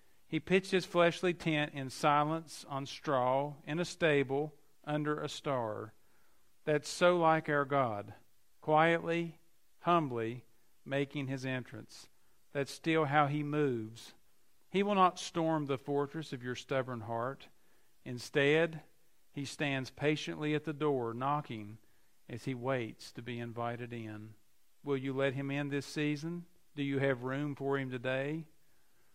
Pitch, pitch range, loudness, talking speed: 145 Hz, 130-155 Hz, -34 LUFS, 140 wpm